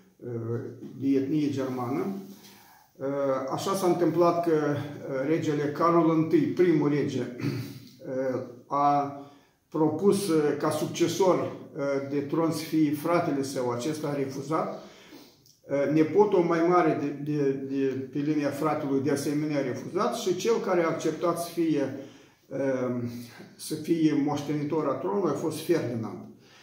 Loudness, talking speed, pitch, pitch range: -27 LUFS, 120 wpm, 150 Hz, 135-165 Hz